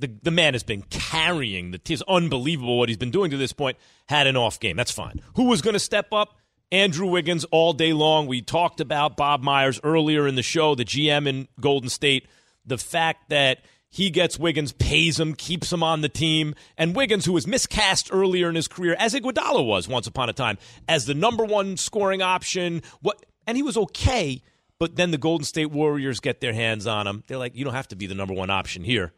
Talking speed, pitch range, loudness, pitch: 225 wpm, 130-175 Hz, -23 LUFS, 155 Hz